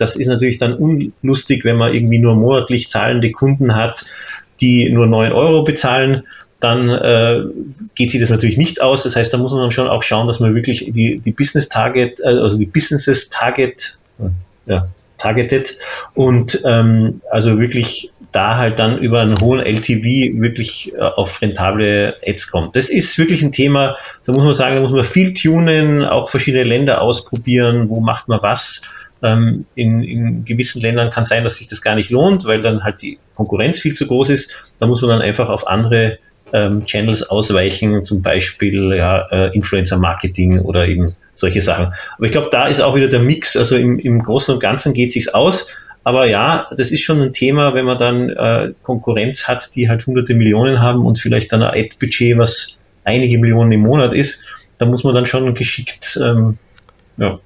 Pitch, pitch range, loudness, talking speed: 120 Hz, 110-130 Hz, -14 LUFS, 190 wpm